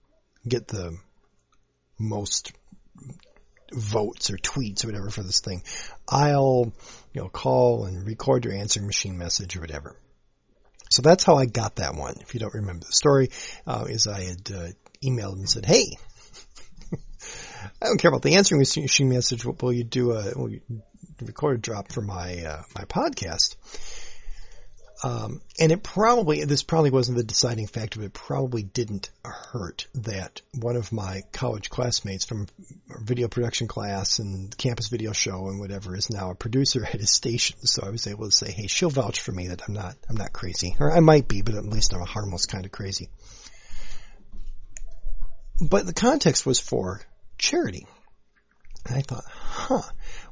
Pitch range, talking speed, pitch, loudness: 100-125 Hz, 170 wpm, 110 Hz, -24 LUFS